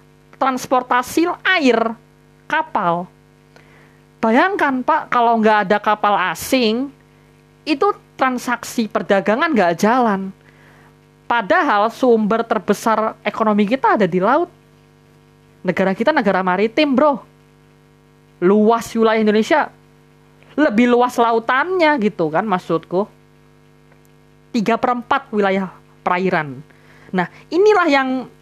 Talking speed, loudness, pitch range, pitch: 95 wpm, -17 LUFS, 195-265 Hz, 225 Hz